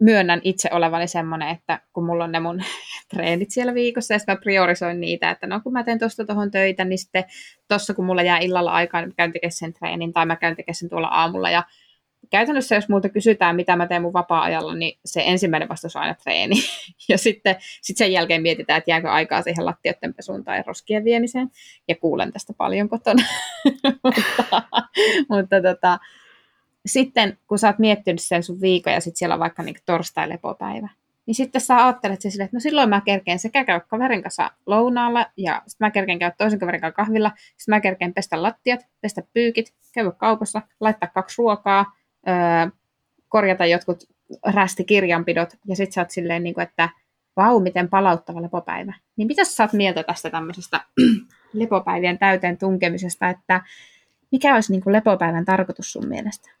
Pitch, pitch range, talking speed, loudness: 195 Hz, 175-220 Hz, 175 wpm, -20 LUFS